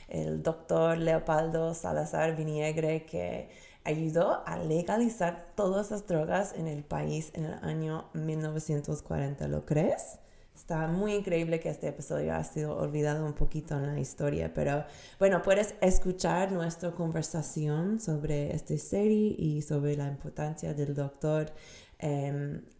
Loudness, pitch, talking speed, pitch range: -32 LUFS, 155 Hz, 135 wpm, 145-170 Hz